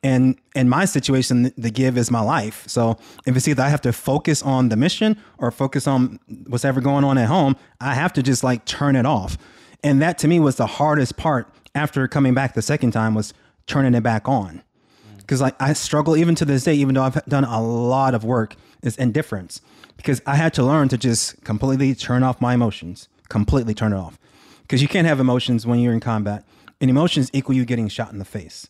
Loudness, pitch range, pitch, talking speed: -19 LUFS, 115-140 Hz, 130 Hz, 225 wpm